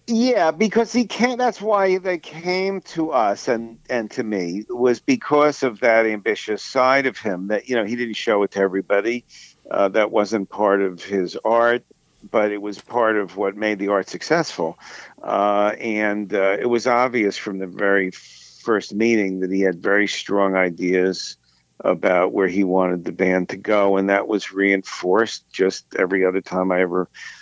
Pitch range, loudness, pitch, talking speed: 95-125 Hz, -20 LUFS, 105 Hz, 180 wpm